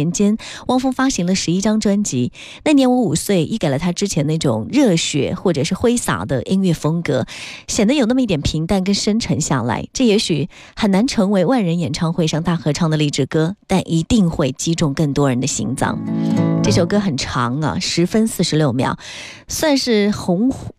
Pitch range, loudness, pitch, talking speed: 155-215 Hz, -17 LUFS, 175 Hz, 285 characters per minute